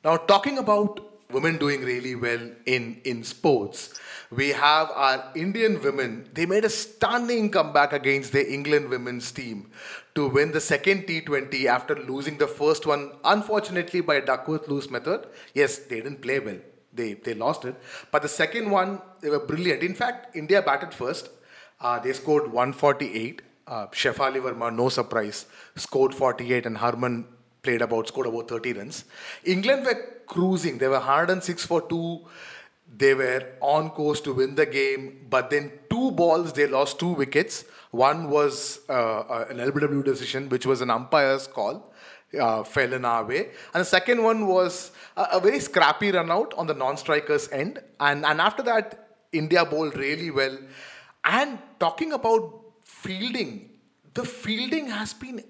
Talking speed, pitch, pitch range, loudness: 165 wpm, 150 Hz, 135-195 Hz, -25 LUFS